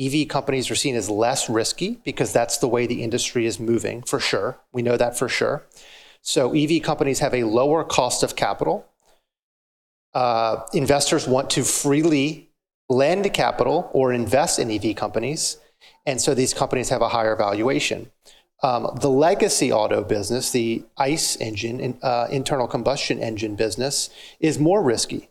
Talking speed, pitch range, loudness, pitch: 160 wpm, 115-140 Hz, -21 LUFS, 125 Hz